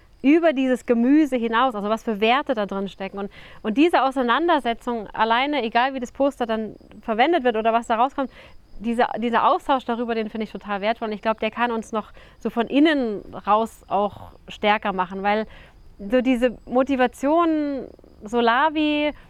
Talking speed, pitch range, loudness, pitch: 170 wpm, 220-265 Hz, -22 LUFS, 235 Hz